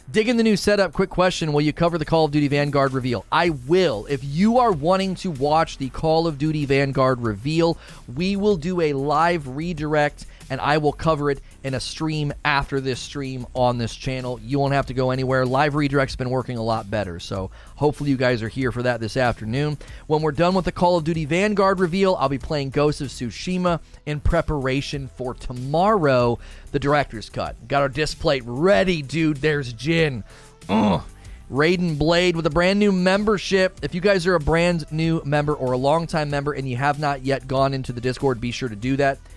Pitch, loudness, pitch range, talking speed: 145 Hz, -21 LUFS, 130-165 Hz, 210 wpm